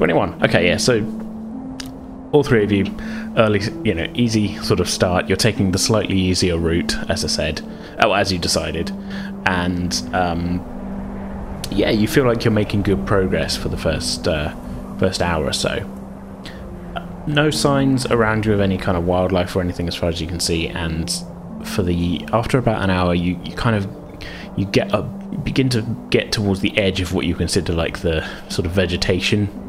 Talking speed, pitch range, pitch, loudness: 190 wpm, 90-115 Hz, 95 Hz, -19 LUFS